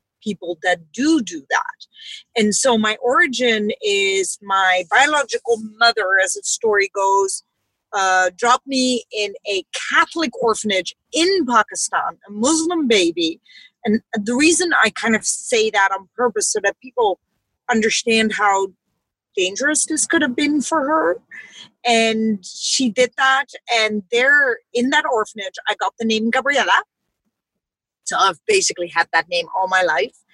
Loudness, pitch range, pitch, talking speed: -18 LUFS, 210-300 Hz, 235 Hz, 145 wpm